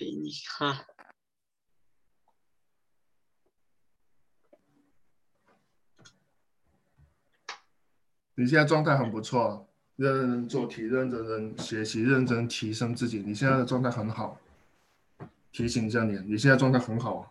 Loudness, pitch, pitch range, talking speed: -28 LUFS, 120 Hz, 110-130 Hz, 165 characters per minute